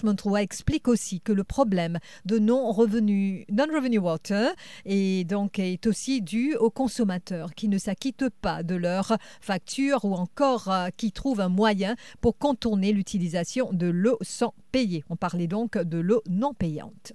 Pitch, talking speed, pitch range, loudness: 205 Hz, 160 wpm, 185-235 Hz, -26 LUFS